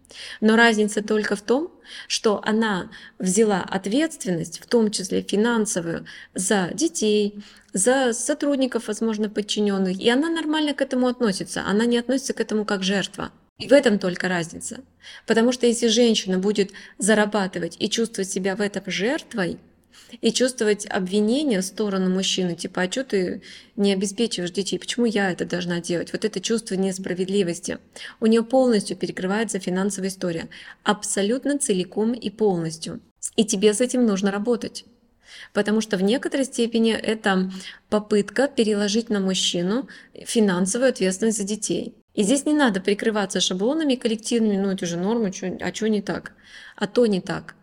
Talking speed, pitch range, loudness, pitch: 150 wpm, 190-235 Hz, -22 LUFS, 210 Hz